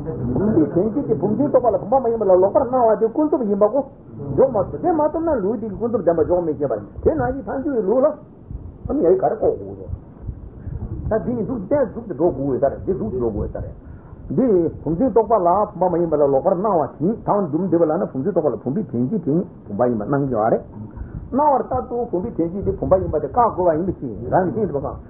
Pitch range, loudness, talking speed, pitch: 165-255 Hz, -20 LUFS, 175 wpm, 205 Hz